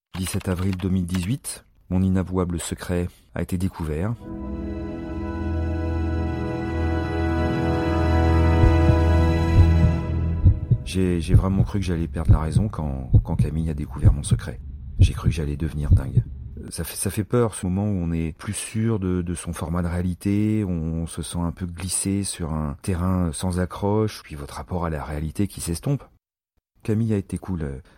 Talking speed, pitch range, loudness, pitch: 155 wpm, 80-95 Hz, -24 LUFS, 85 Hz